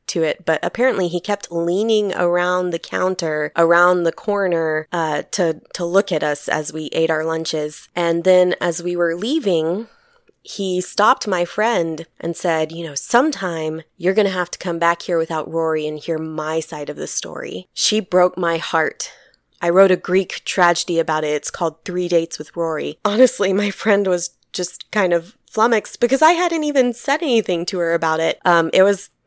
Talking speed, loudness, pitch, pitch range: 190 wpm, -18 LUFS, 175 Hz, 160-195 Hz